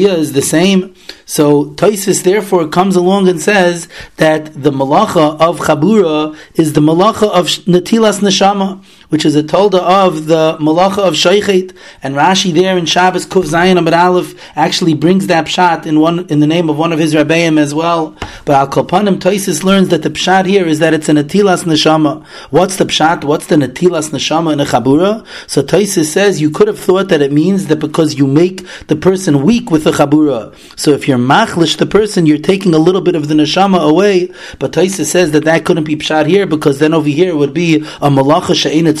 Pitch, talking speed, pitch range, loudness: 170 Hz, 205 wpm, 155-185 Hz, -11 LUFS